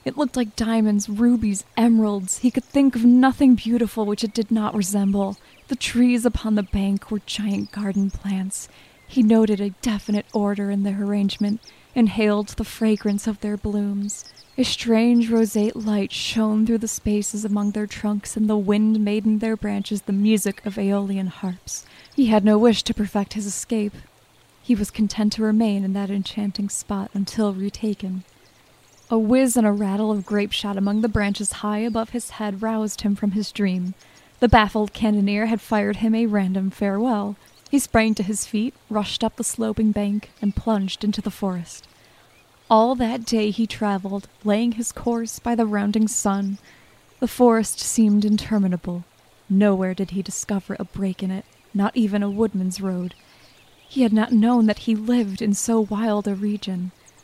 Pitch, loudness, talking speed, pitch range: 210 Hz, -22 LUFS, 175 wpm, 200-225 Hz